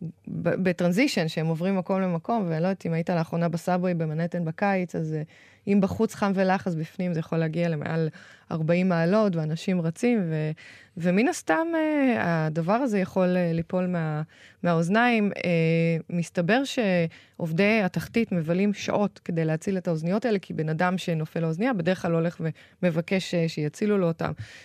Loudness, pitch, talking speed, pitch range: -26 LUFS, 175 Hz, 150 wpm, 165-195 Hz